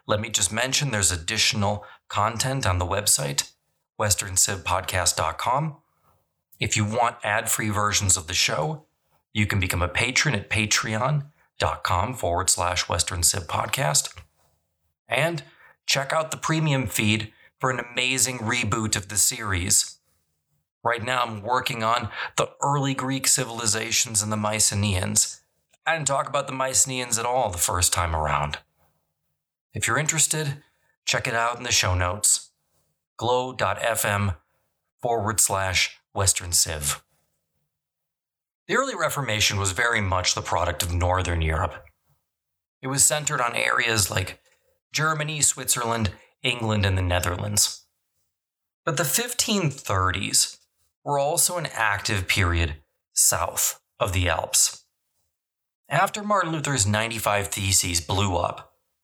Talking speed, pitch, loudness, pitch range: 125 wpm, 105 Hz, -23 LUFS, 90-130 Hz